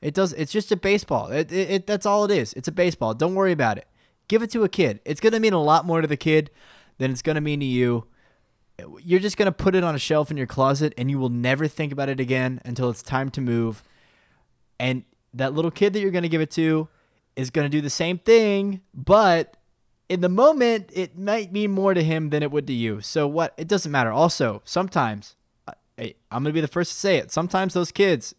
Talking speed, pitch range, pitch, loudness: 255 wpm, 135-190 Hz, 160 Hz, -22 LUFS